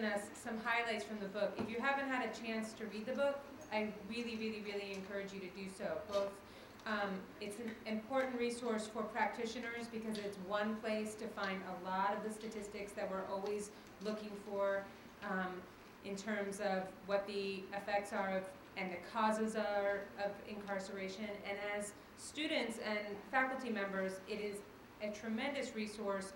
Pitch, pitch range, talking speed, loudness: 210 Hz, 200-220 Hz, 170 wpm, -41 LUFS